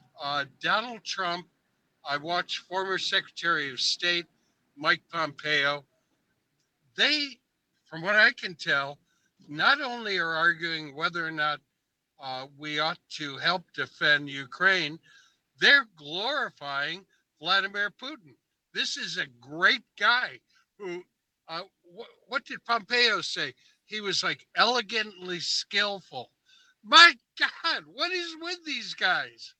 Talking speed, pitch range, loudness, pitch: 120 wpm, 155-245 Hz, -26 LUFS, 185 Hz